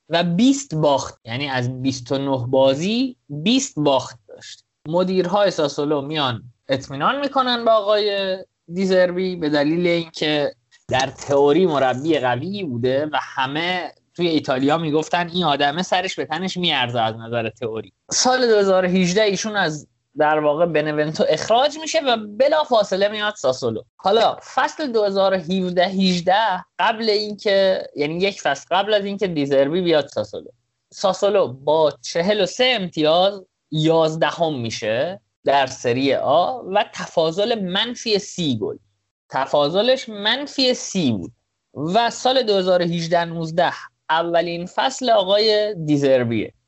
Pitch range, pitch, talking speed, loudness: 145-205 Hz, 175 Hz, 125 wpm, -20 LUFS